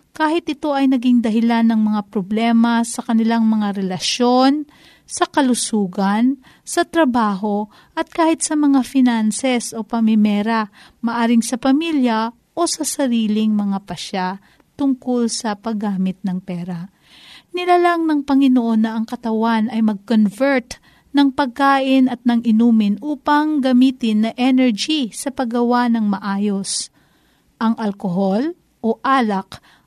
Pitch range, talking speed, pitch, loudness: 215-270 Hz, 125 wpm, 235 Hz, -18 LUFS